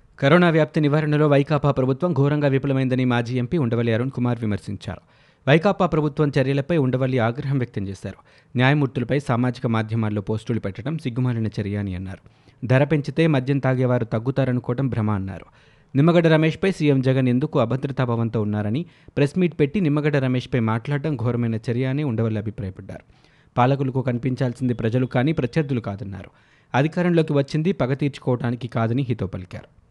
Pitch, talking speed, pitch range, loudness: 130 Hz, 135 wpm, 115-145 Hz, -22 LUFS